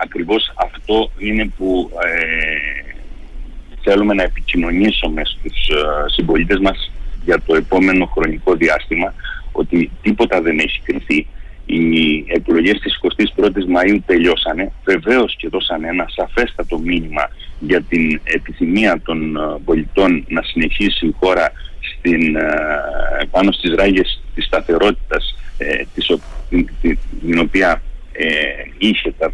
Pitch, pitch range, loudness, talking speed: 85 Hz, 80-95 Hz, -16 LUFS, 125 wpm